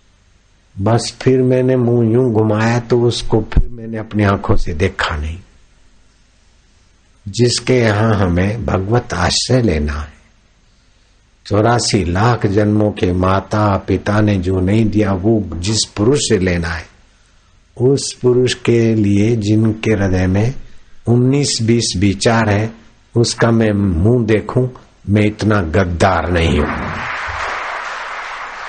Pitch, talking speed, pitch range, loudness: 105 Hz, 120 wpm, 95-115 Hz, -15 LUFS